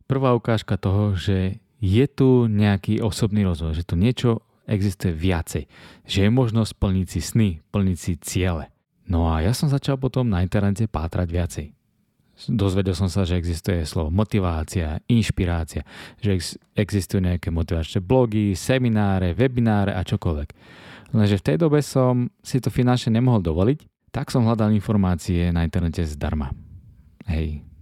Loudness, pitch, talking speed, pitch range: -22 LUFS, 100 Hz, 145 wpm, 90-115 Hz